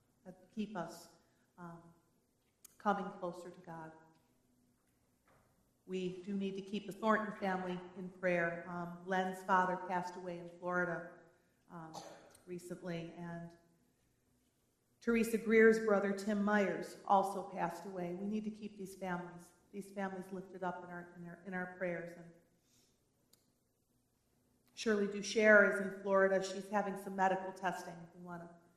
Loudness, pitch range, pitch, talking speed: -36 LUFS, 170-195 Hz, 180 Hz, 140 wpm